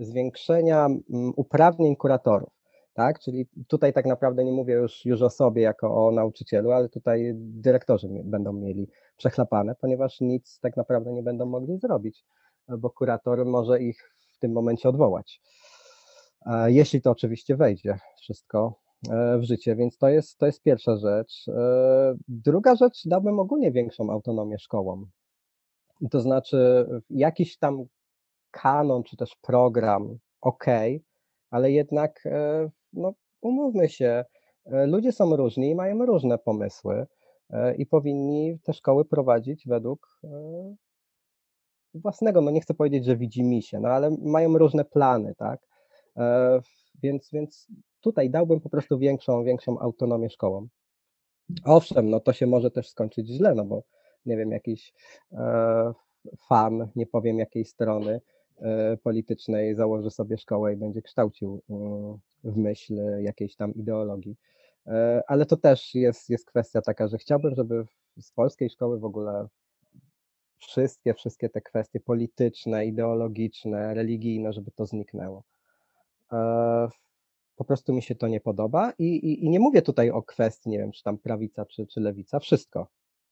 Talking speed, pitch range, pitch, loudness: 140 wpm, 110-140 Hz, 120 Hz, -25 LUFS